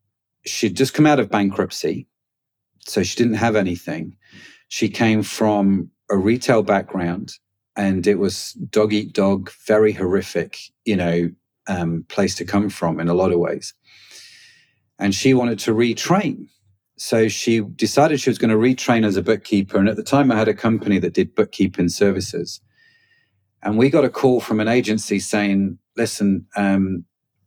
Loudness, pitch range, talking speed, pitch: -19 LUFS, 95-115 Hz, 165 wpm, 105 Hz